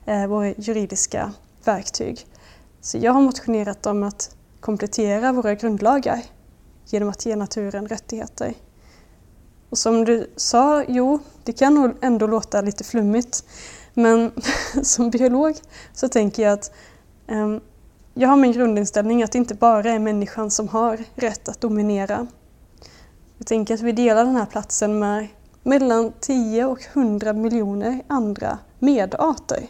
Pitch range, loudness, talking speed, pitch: 210-250 Hz, -20 LUFS, 135 wpm, 230 Hz